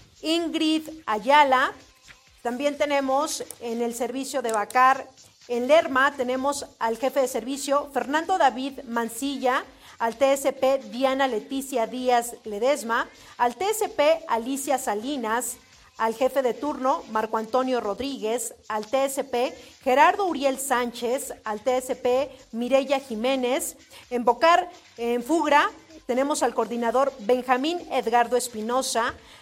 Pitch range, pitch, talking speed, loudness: 240-280 Hz, 260 Hz, 110 wpm, -24 LUFS